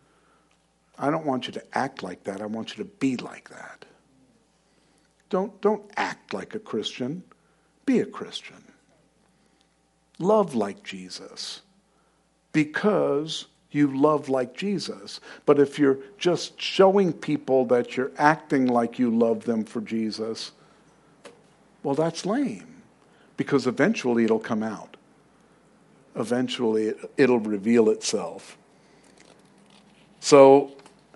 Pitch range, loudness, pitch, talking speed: 115-160 Hz, -24 LUFS, 135 Hz, 115 wpm